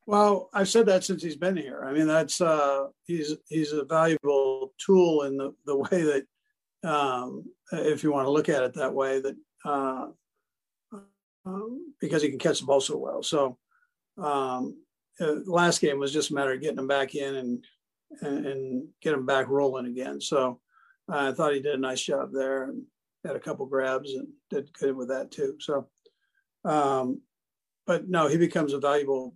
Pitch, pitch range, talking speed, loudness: 145 Hz, 135-185 Hz, 190 wpm, -27 LUFS